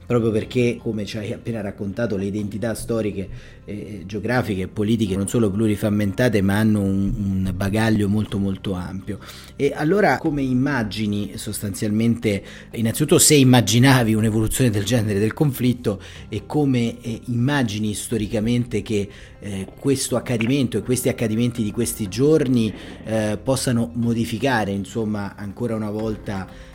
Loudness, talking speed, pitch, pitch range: -21 LUFS, 135 wpm, 110 Hz, 105-120 Hz